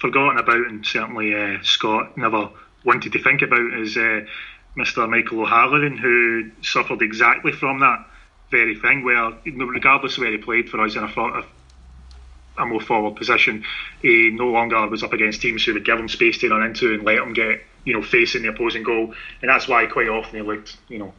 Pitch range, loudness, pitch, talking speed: 105-120 Hz, -18 LUFS, 115 Hz, 200 wpm